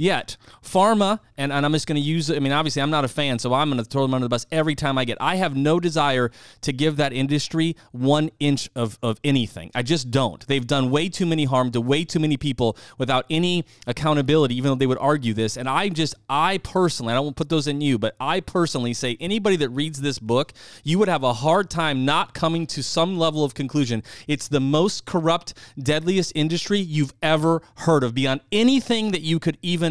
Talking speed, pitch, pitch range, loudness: 235 wpm, 145 Hz, 130-165 Hz, -22 LUFS